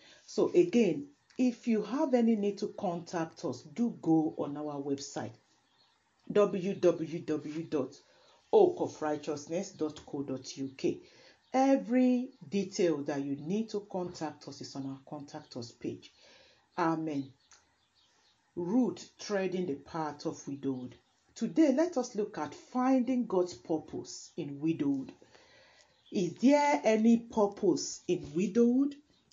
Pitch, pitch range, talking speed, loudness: 180 Hz, 150-235 Hz, 110 wpm, -32 LUFS